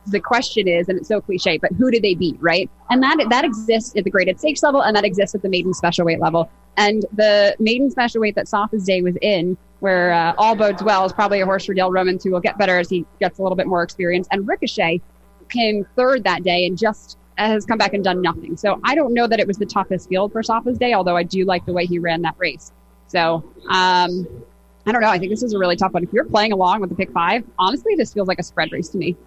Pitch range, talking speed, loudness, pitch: 180-215 Hz, 270 wpm, -18 LUFS, 195 Hz